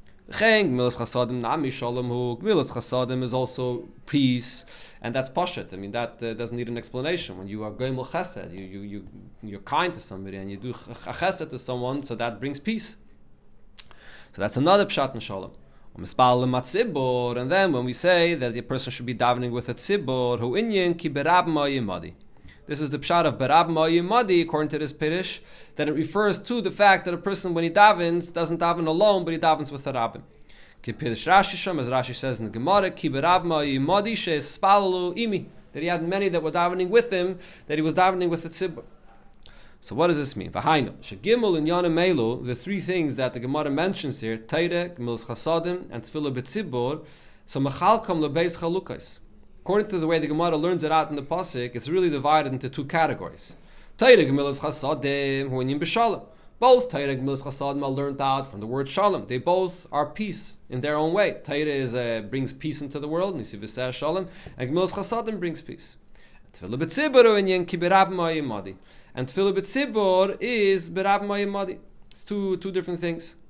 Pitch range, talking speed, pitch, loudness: 125-180 Hz, 170 wpm, 150 Hz, -24 LUFS